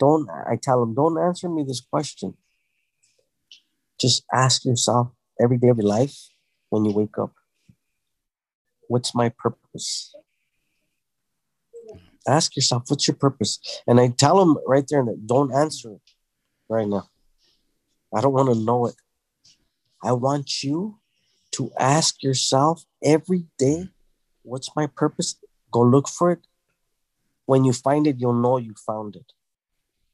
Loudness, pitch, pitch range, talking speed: -22 LUFS, 135 Hz, 120-150 Hz, 140 wpm